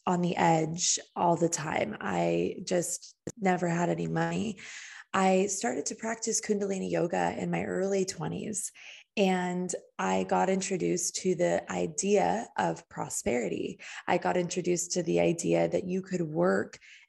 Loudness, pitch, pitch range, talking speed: -30 LUFS, 180 Hz, 165-190 Hz, 145 wpm